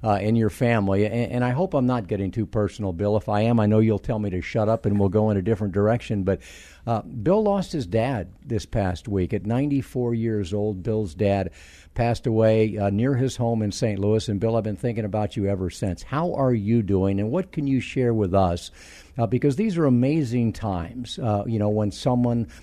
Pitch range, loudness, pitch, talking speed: 100-120 Hz, -23 LUFS, 110 Hz, 230 wpm